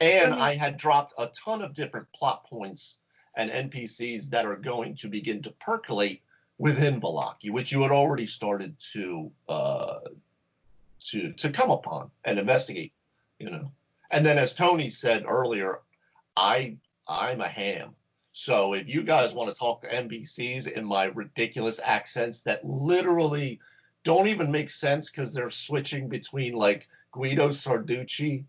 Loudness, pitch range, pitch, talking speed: -27 LUFS, 120-150 Hz, 140 Hz, 150 wpm